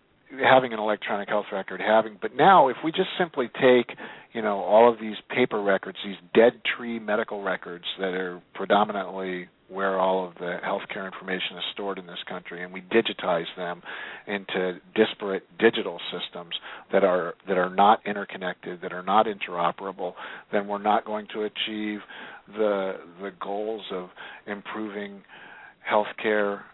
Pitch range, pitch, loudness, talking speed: 95-110 Hz, 100 Hz, -25 LUFS, 155 wpm